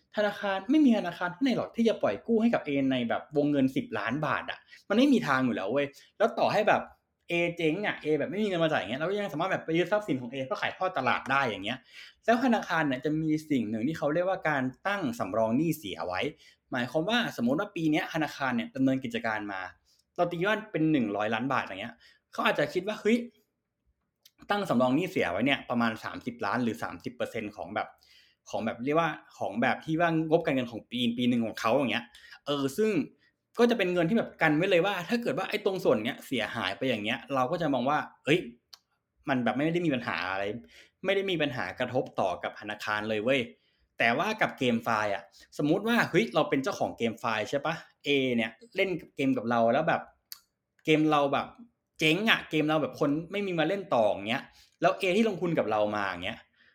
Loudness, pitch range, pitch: -29 LUFS, 130-200 Hz, 155 Hz